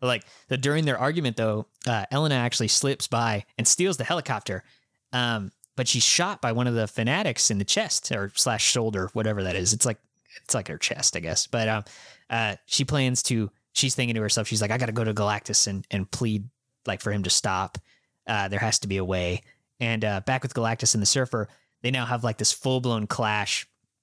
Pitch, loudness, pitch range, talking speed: 115 Hz, -25 LUFS, 105-125 Hz, 225 wpm